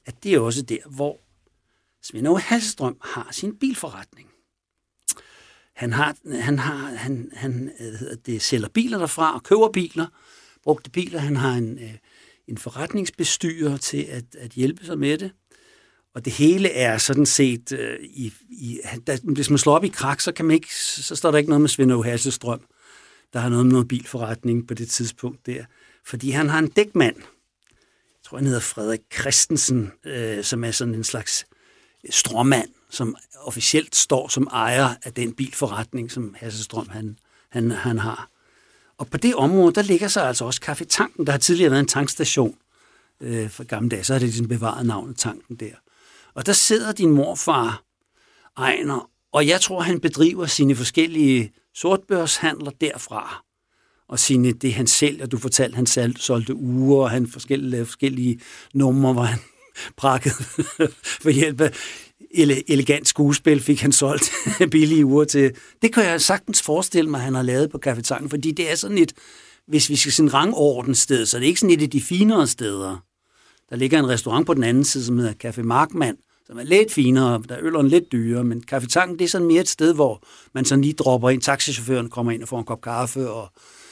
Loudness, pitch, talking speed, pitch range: -20 LUFS, 135 Hz, 190 wpm, 120-155 Hz